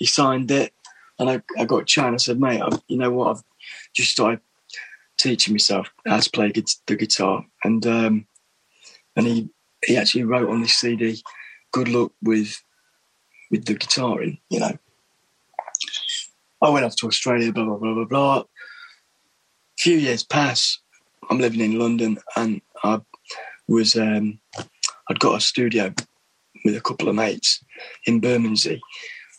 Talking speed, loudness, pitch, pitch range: 160 wpm, -21 LUFS, 115 Hz, 110-125 Hz